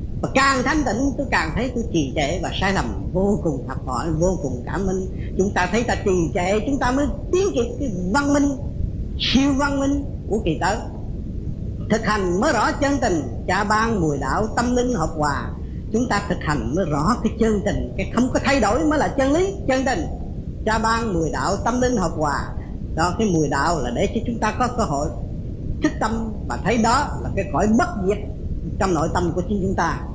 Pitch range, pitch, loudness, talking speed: 180-275 Hz, 225 Hz, -21 LUFS, 225 wpm